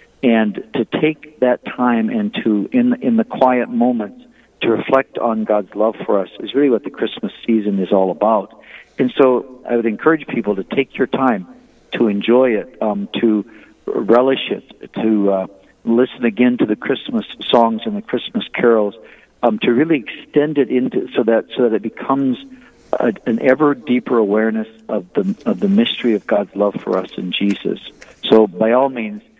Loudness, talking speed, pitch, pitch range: -17 LUFS, 185 wpm, 125 Hz, 110-185 Hz